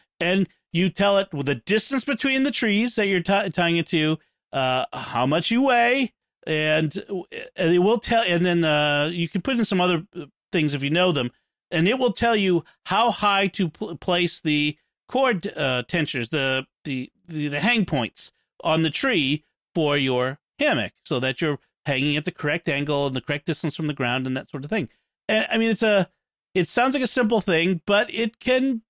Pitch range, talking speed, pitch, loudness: 150-215 Hz, 210 wpm, 175 Hz, -23 LUFS